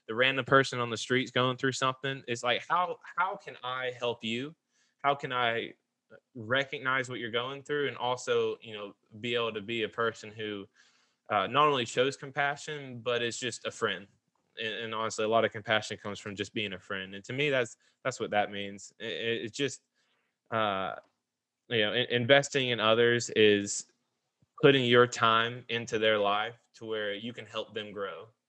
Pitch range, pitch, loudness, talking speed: 110-130 Hz, 120 Hz, -30 LUFS, 195 wpm